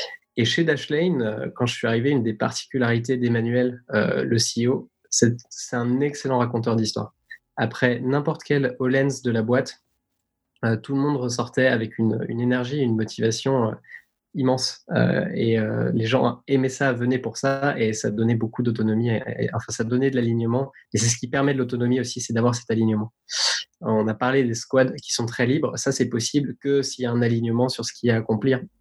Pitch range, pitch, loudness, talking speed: 115-135 Hz, 125 Hz, -23 LUFS, 210 wpm